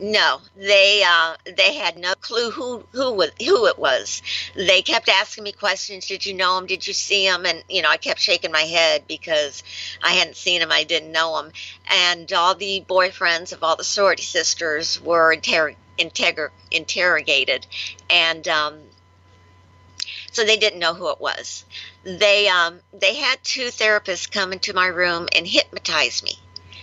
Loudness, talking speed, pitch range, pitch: -19 LUFS, 170 wpm, 160-205 Hz, 185 Hz